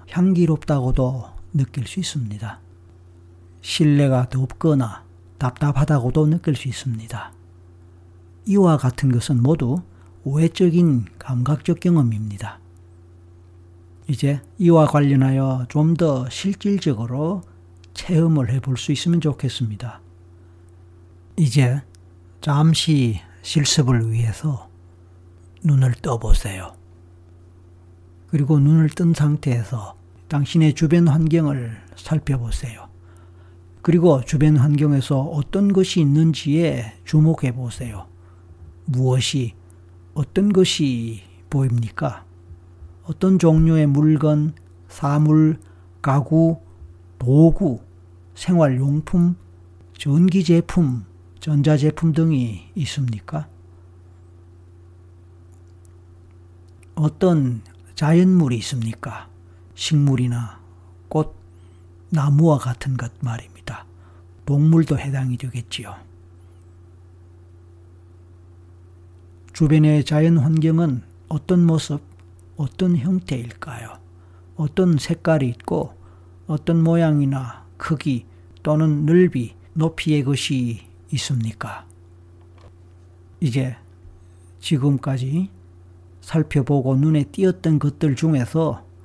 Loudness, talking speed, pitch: -19 LUFS, 195 characters per minute, 125 Hz